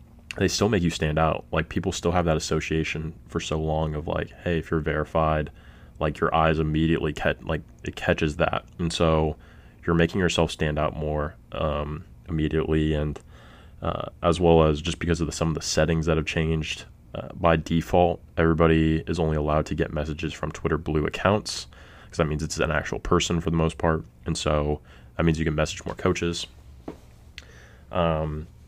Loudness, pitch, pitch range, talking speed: -25 LUFS, 80 Hz, 75-85 Hz, 190 wpm